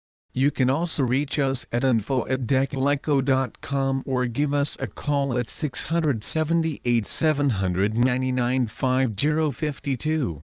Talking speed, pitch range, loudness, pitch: 85 wpm, 125-145 Hz, -24 LUFS, 135 Hz